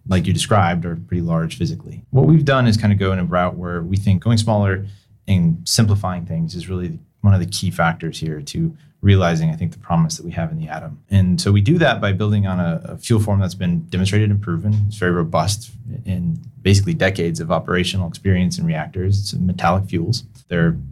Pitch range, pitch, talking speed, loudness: 85-105 Hz, 95 Hz, 220 wpm, -19 LUFS